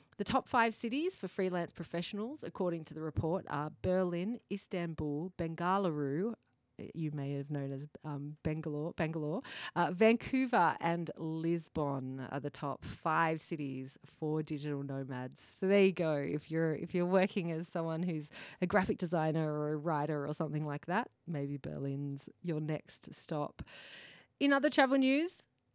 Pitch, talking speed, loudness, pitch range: 165 Hz, 155 wpm, -35 LUFS, 150-190 Hz